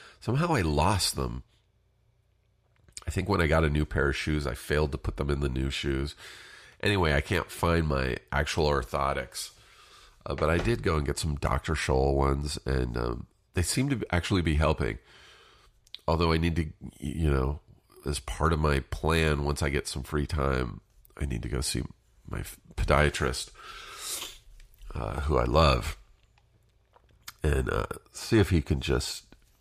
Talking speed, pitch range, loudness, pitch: 170 wpm, 70-95 Hz, -29 LUFS, 75 Hz